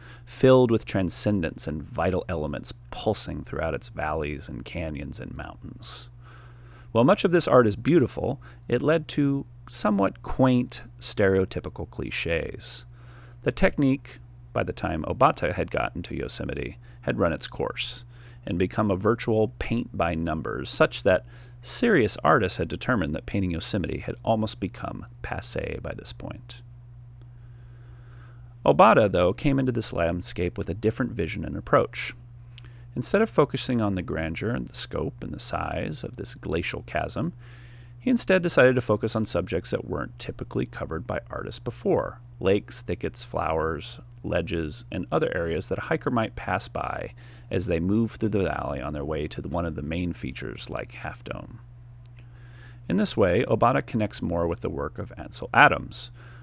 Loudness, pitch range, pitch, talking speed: -26 LUFS, 95-120 Hz, 120 Hz, 160 wpm